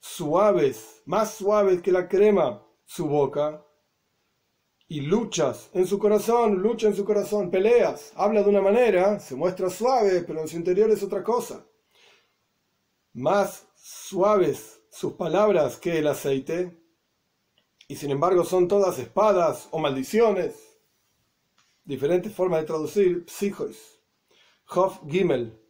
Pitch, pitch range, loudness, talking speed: 190 Hz, 165-210 Hz, -23 LUFS, 125 wpm